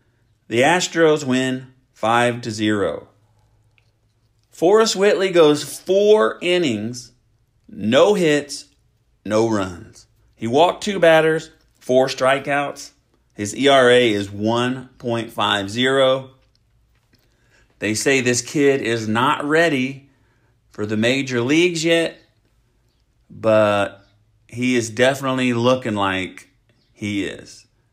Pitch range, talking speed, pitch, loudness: 110-135 Hz, 95 wpm, 120 Hz, -18 LUFS